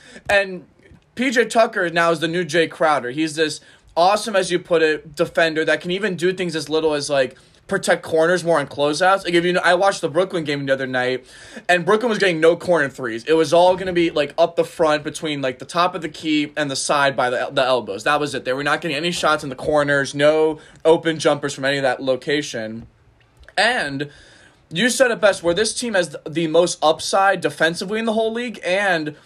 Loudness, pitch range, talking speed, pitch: -19 LUFS, 150-180 Hz, 230 wpm, 165 Hz